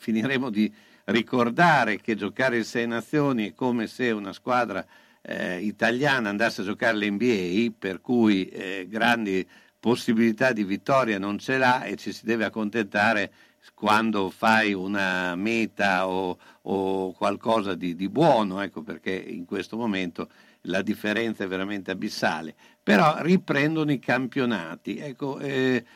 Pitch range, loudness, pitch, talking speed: 95-120 Hz, -25 LUFS, 110 Hz, 140 wpm